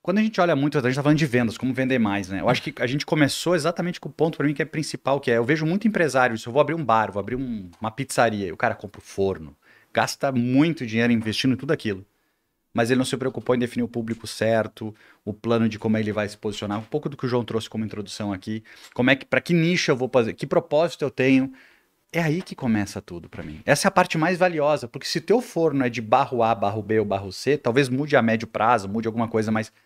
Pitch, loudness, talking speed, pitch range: 125 Hz, -23 LUFS, 275 wpm, 110-150 Hz